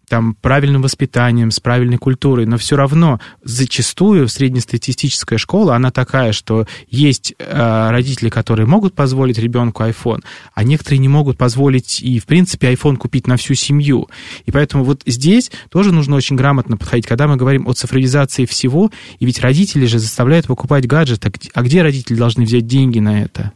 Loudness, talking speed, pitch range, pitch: -14 LUFS, 170 wpm, 120-140 Hz, 130 Hz